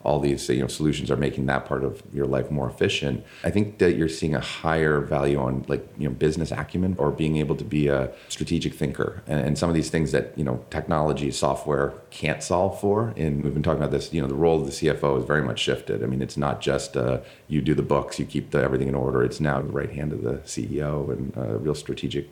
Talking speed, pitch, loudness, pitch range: 255 wpm, 75 Hz, -25 LUFS, 70-80 Hz